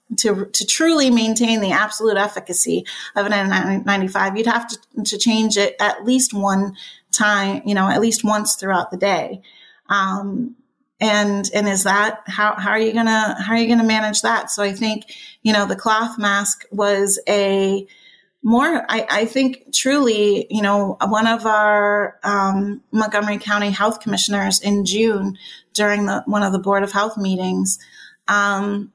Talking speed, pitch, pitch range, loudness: 170 wpm, 210 Hz, 200-225 Hz, -18 LUFS